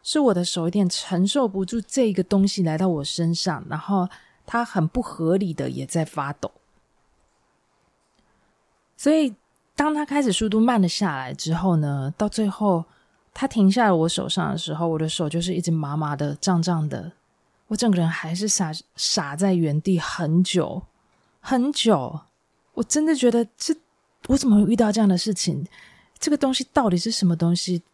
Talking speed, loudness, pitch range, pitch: 250 characters per minute, -22 LUFS, 170-225 Hz, 185 Hz